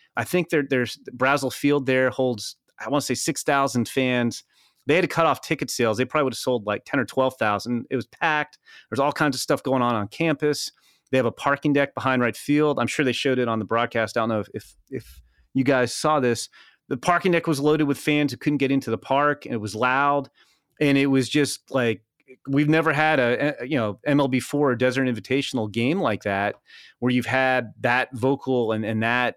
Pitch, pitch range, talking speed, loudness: 130 Hz, 120-145 Hz, 235 wpm, -23 LUFS